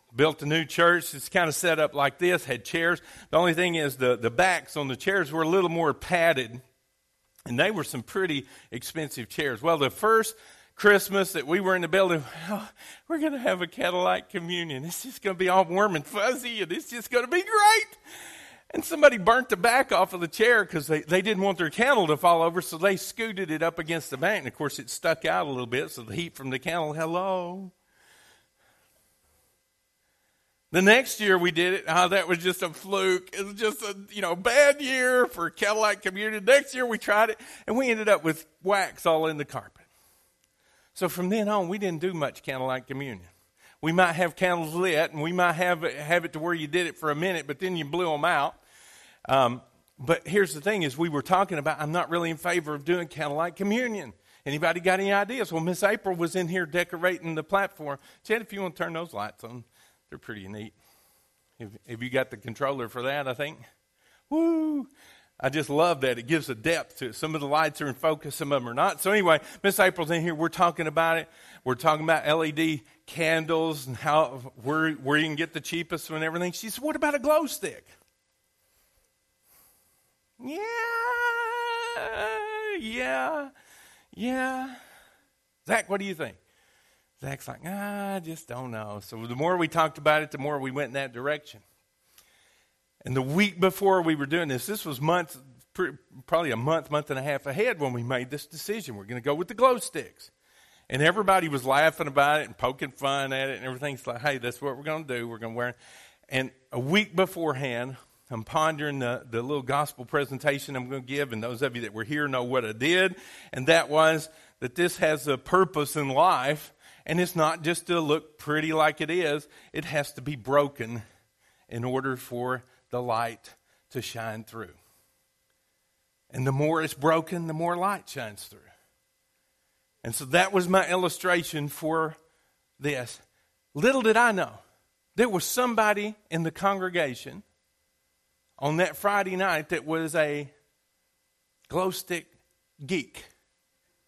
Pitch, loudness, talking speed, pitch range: 160 Hz, -26 LUFS, 200 wpm, 135-190 Hz